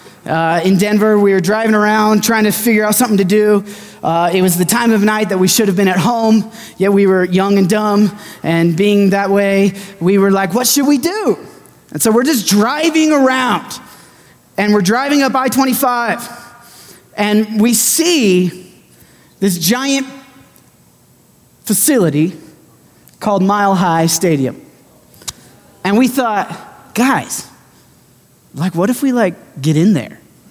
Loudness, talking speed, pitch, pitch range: -13 LUFS, 155 wpm, 210 Hz, 190-235 Hz